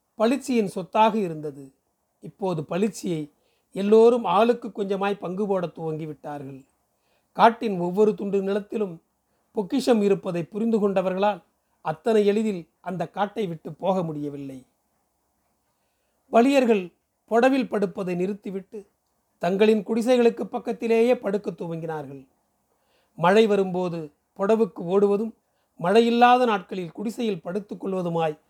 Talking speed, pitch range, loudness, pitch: 90 wpm, 175-225 Hz, -23 LUFS, 200 Hz